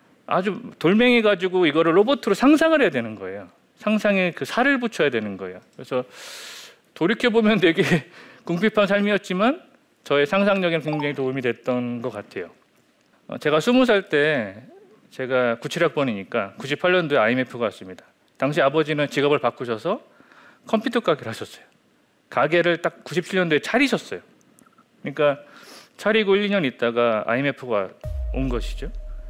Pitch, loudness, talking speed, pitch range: 170 Hz, -21 LUFS, 315 characters per minute, 130-210 Hz